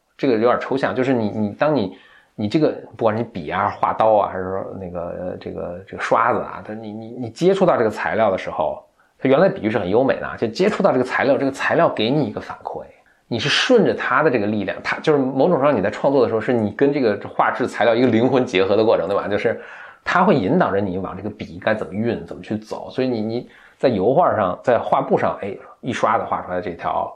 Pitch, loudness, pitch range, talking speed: 110 Hz, -19 LUFS, 100-130 Hz, 360 characters per minute